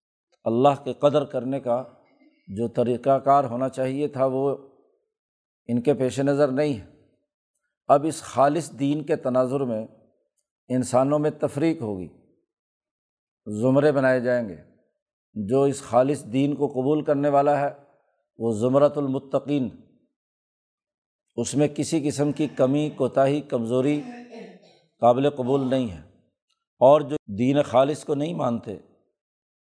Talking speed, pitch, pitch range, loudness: 130 wpm, 140 Hz, 125-150 Hz, -23 LUFS